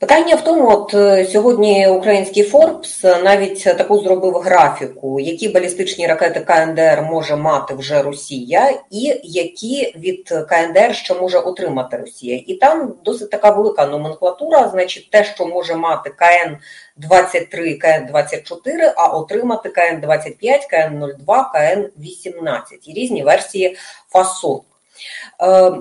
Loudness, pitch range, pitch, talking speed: -15 LUFS, 165-210 Hz, 185 Hz, 125 wpm